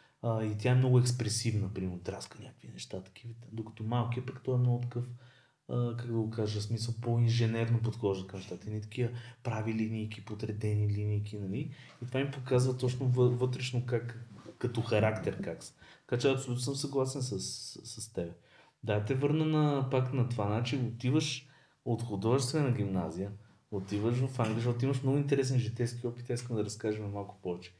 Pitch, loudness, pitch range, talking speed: 120 Hz, -33 LUFS, 105-130 Hz, 180 wpm